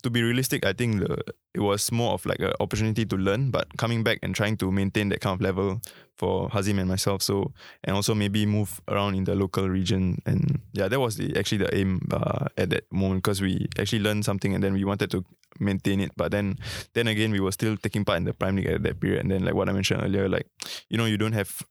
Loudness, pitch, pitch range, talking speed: -26 LUFS, 100 Hz, 95-110 Hz, 255 wpm